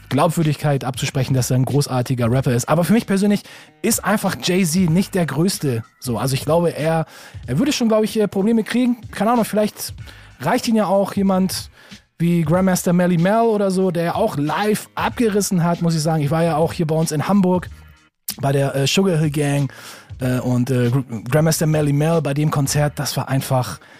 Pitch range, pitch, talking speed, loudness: 135-195 Hz, 160 Hz, 200 wpm, -19 LUFS